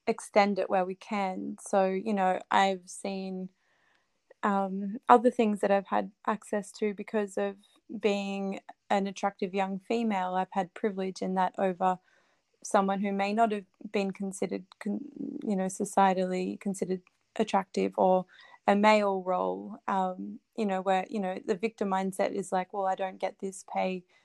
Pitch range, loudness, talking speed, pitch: 190-210 Hz, -30 LUFS, 160 wpm, 195 Hz